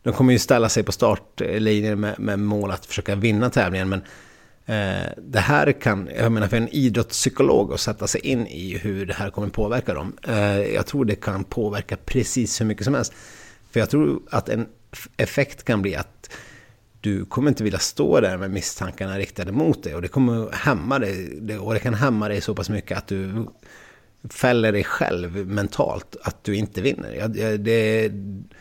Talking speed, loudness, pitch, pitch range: 195 wpm, -22 LUFS, 105 Hz, 100-115 Hz